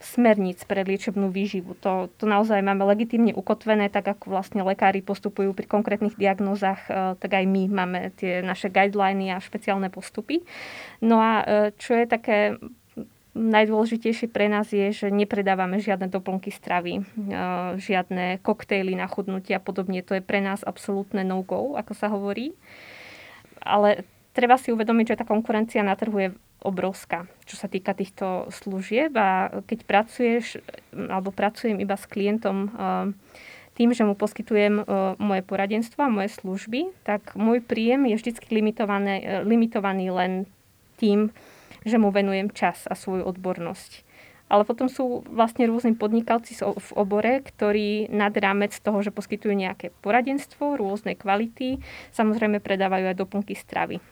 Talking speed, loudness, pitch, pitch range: 140 wpm, -24 LUFS, 205 Hz, 195-220 Hz